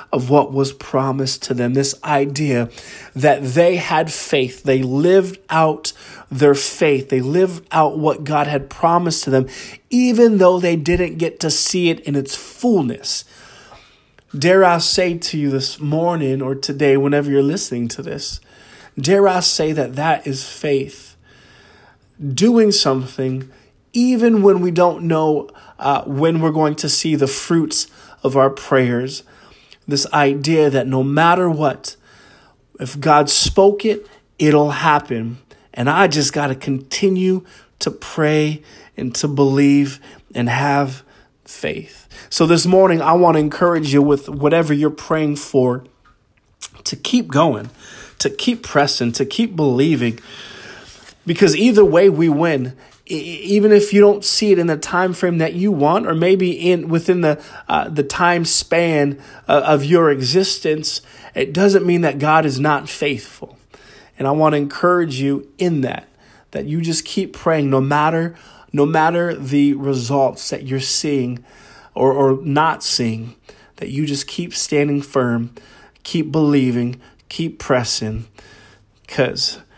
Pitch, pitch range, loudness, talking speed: 150 Hz, 135-170 Hz, -16 LUFS, 150 wpm